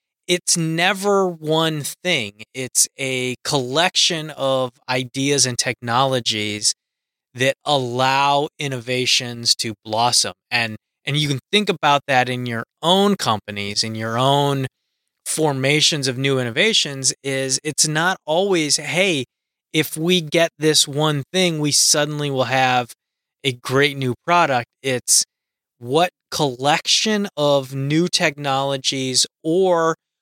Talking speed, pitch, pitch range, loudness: 120 wpm, 140 Hz, 125-160 Hz, -18 LUFS